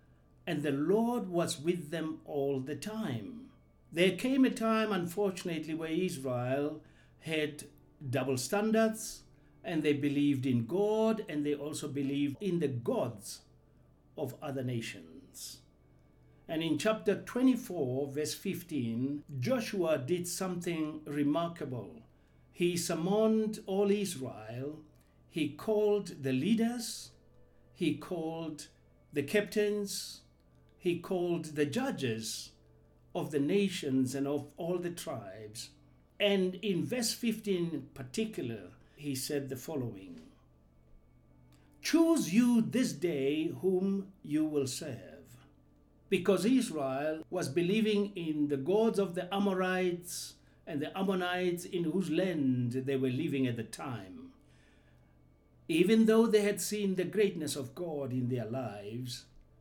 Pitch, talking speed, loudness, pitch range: 155 Hz, 120 wpm, -33 LUFS, 125-195 Hz